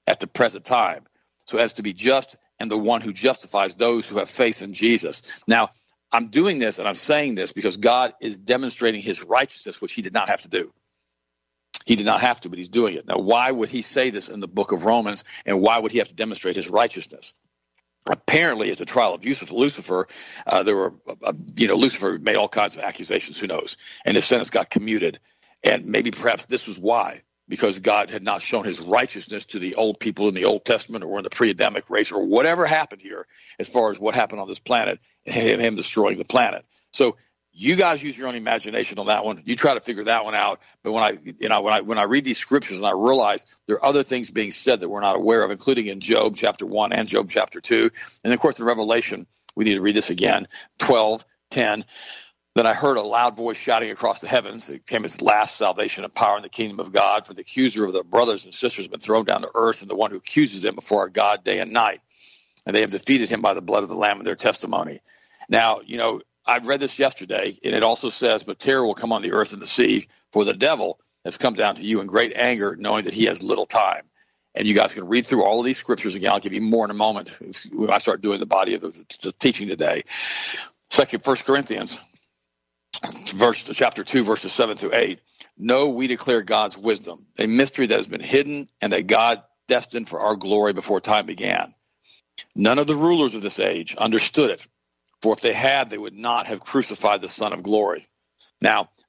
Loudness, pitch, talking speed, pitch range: -21 LUFS, 115 Hz, 235 wpm, 105-135 Hz